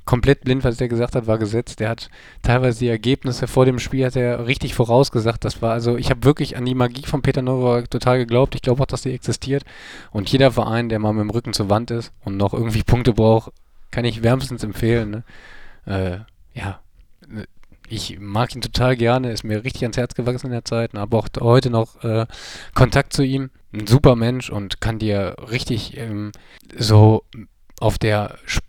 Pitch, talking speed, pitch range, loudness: 120 Hz, 205 wpm, 110-130 Hz, -20 LUFS